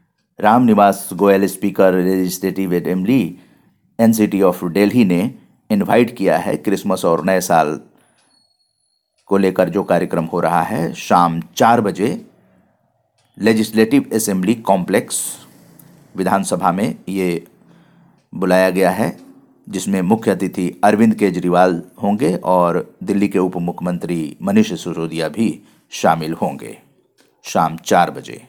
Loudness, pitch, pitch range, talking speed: -16 LUFS, 95 Hz, 90-100 Hz, 120 wpm